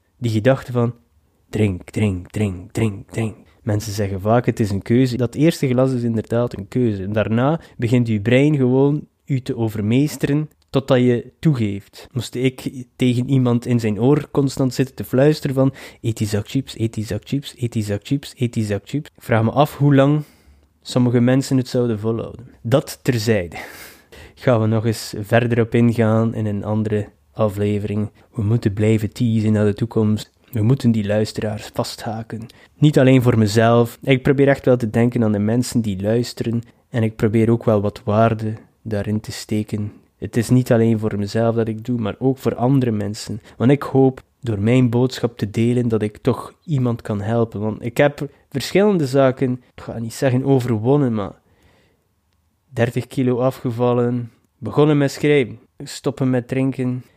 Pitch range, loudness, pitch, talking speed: 110-130 Hz, -19 LUFS, 120 Hz, 180 wpm